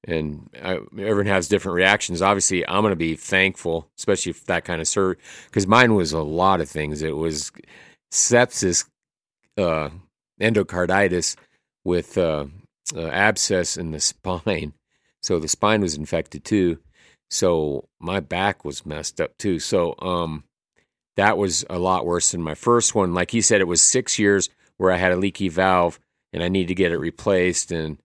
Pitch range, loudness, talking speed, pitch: 80-95 Hz, -21 LUFS, 175 wpm, 90 Hz